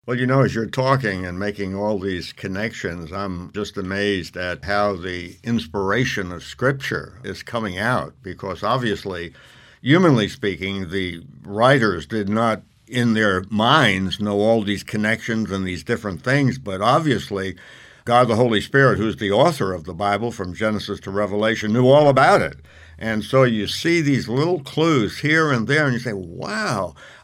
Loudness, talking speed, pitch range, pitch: -20 LUFS, 165 wpm, 95-120 Hz, 105 Hz